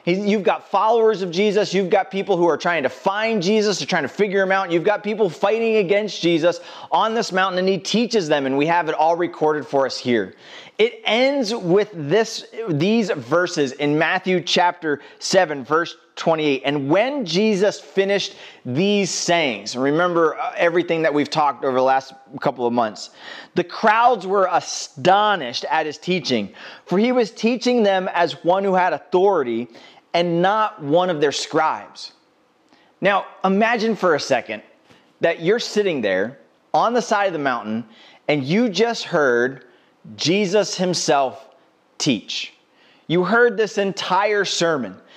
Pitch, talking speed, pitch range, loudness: 180 Hz, 160 wpm, 155-210 Hz, -19 LUFS